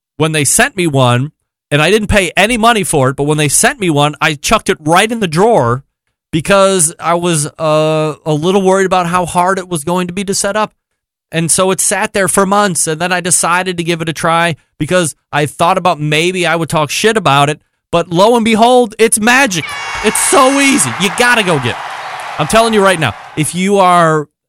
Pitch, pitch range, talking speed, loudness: 175 Hz, 155-200 Hz, 230 wpm, -11 LUFS